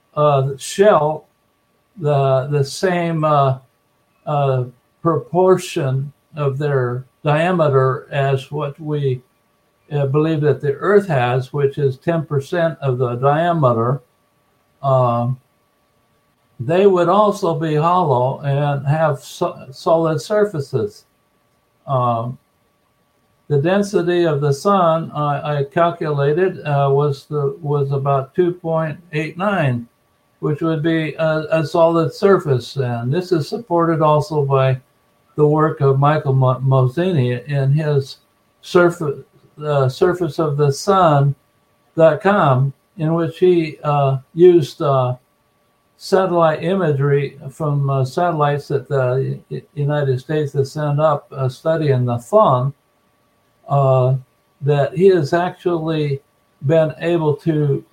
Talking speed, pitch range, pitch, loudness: 115 wpm, 135-165 Hz, 145 Hz, -17 LUFS